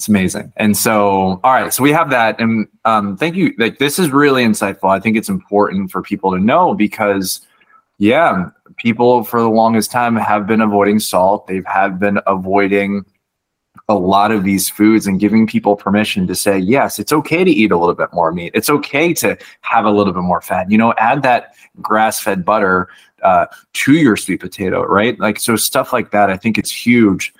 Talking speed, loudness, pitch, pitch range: 205 wpm, -14 LUFS, 105 Hz, 100-115 Hz